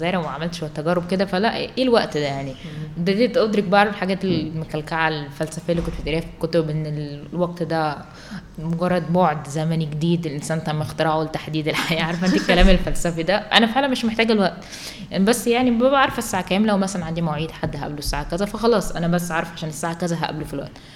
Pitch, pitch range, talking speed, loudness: 165 Hz, 155-190 Hz, 190 wpm, -21 LUFS